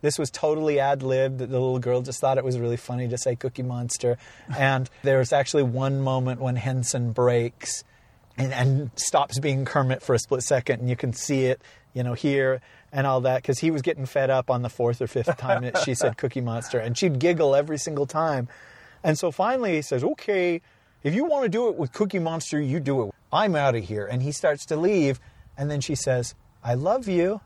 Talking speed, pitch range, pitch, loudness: 225 wpm, 125-150 Hz, 135 Hz, -25 LUFS